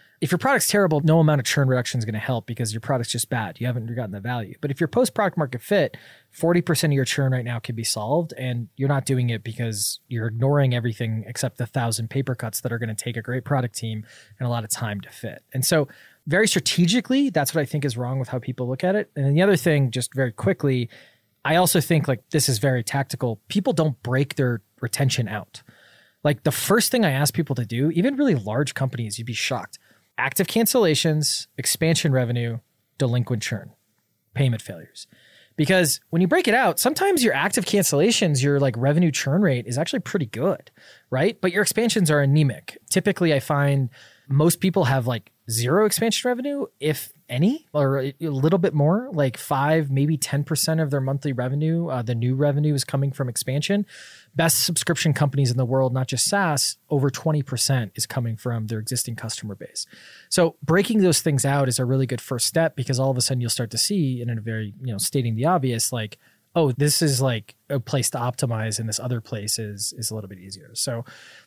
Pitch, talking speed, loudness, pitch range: 135 Hz, 215 wpm, -22 LUFS, 120-160 Hz